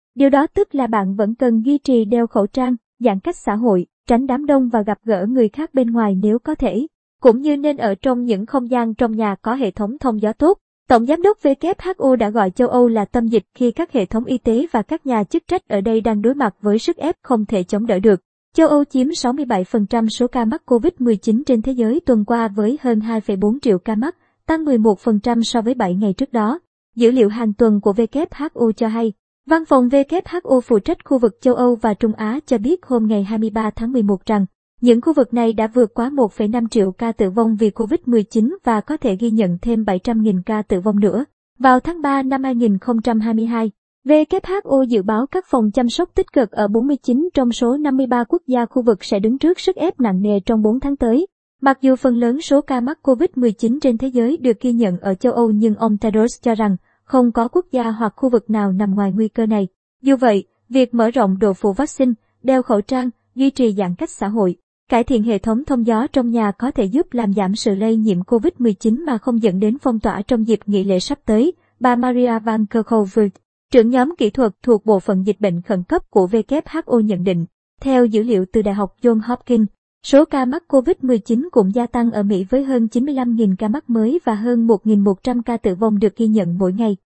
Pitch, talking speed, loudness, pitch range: 235 Hz, 225 wpm, -17 LUFS, 215-260 Hz